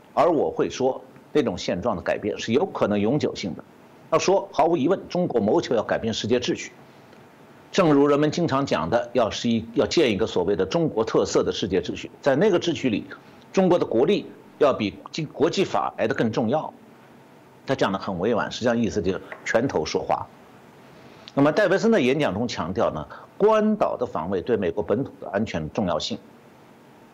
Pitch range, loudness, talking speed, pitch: 115-190 Hz, -23 LUFS, 285 characters per minute, 140 Hz